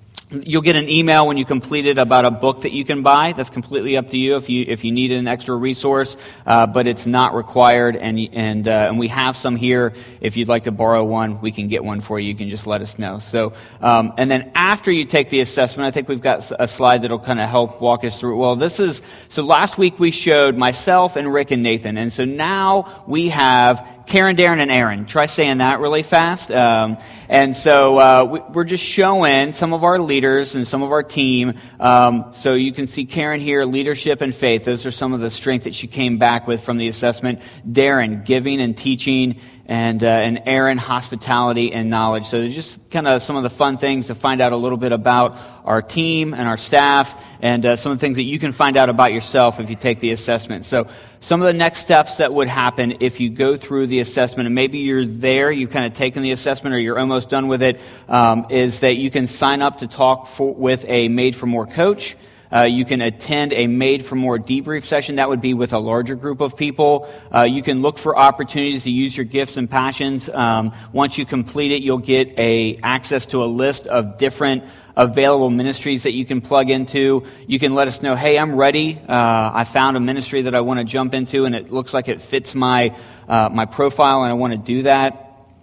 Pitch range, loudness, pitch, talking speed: 120-140 Hz, -17 LUFS, 130 Hz, 235 wpm